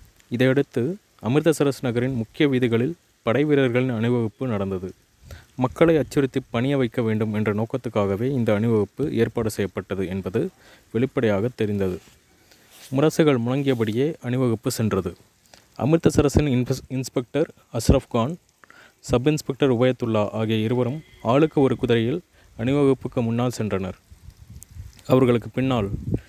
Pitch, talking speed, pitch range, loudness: 120 Hz, 100 wpm, 105-130 Hz, -23 LUFS